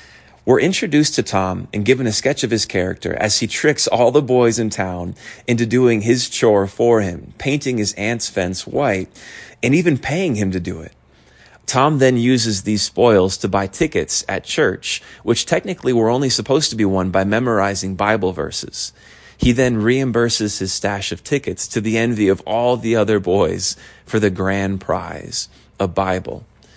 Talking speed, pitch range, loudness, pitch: 180 wpm, 95-125 Hz, -17 LUFS, 110 Hz